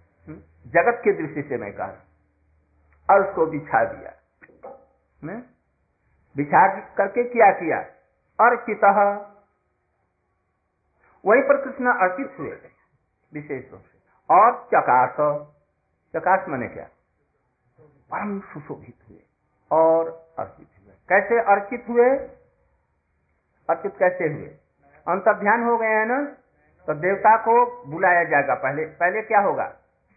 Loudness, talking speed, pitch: -20 LUFS, 105 wpm, 160 Hz